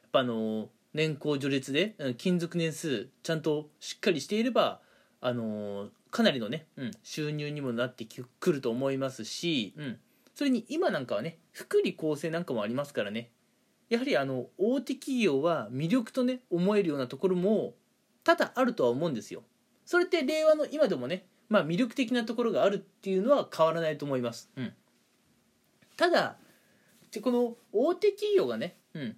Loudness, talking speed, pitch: -30 LUFS, 350 characters per minute, 180 Hz